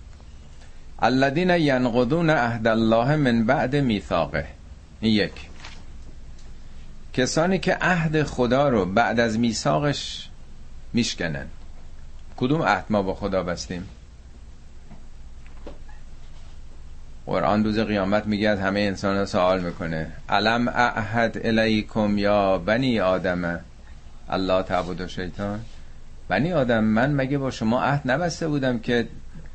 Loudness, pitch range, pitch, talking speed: -23 LUFS, 75-115 Hz, 95 Hz, 105 wpm